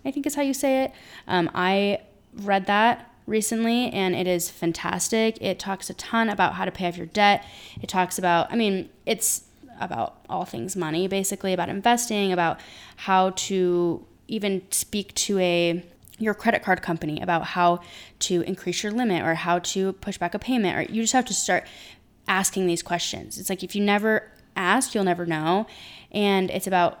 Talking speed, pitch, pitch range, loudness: 190 wpm, 190 Hz, 175-210 Hz, -24 LUFS